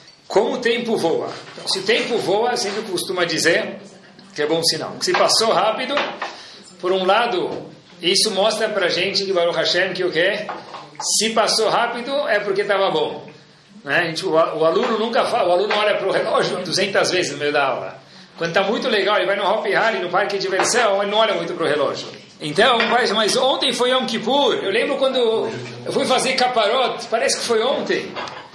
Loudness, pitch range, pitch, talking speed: -19 LUFS, 175-230 Hz, 195 Hz, 205 wpm